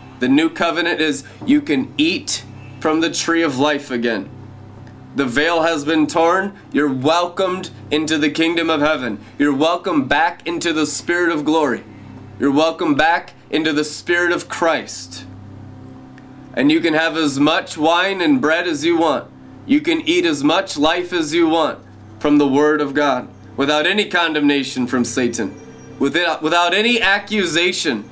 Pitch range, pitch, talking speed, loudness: 135-175 Hz, 155 Hz, 160 wpm, -17 LUFS